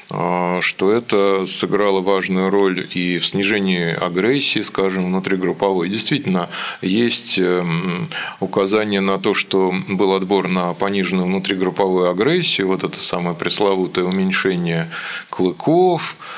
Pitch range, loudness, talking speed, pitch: 90-100 Hz, -18 LUFS, 105 wpm, 95 Hz